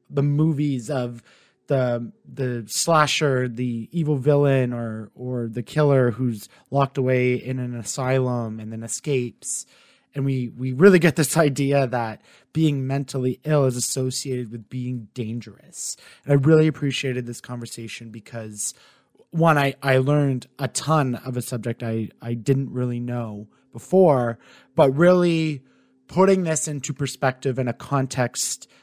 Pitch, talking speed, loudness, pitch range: 130 Hz, 145 wpm, -22 LUFS, 120-145 Hz